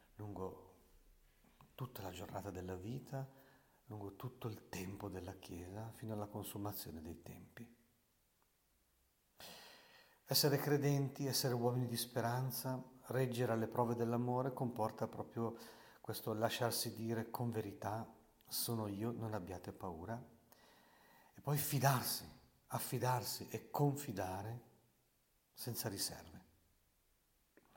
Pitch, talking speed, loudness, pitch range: 115 Hz, 100 wpm, -42 LUFS, 100-125 Hz